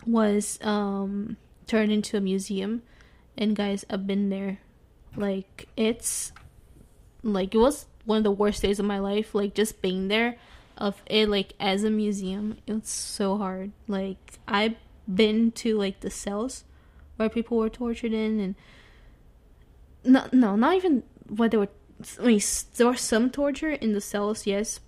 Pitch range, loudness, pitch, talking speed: 200-225 Hz, -26 LUFS, 210 Hz, 160 wpm